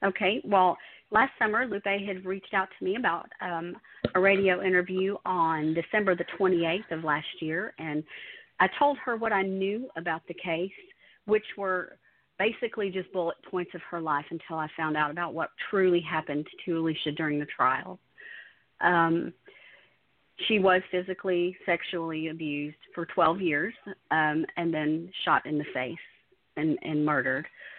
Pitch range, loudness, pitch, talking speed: 160-195 Hz, -28 LUFS, 175 Hz, 160 wpm